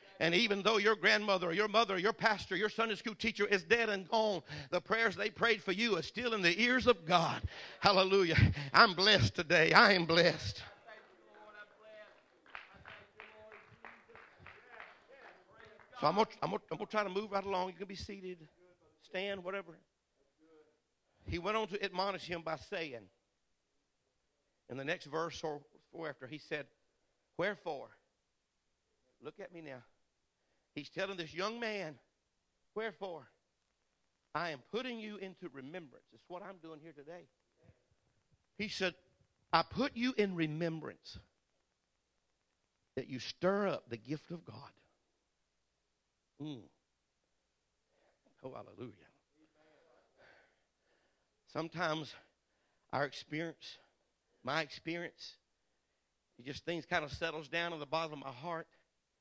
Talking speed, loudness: 130 wpm, -34 LUFS